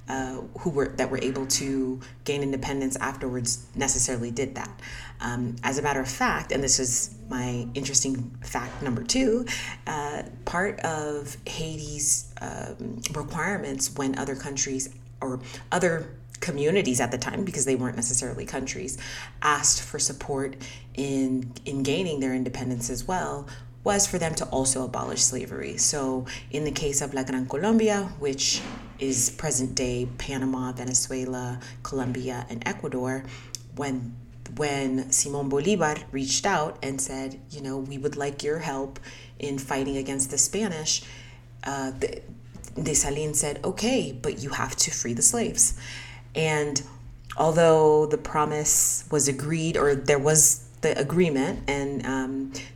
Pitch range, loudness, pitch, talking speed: 125-145 Hz, -26 LUFS, 135 Hz, 145 wpm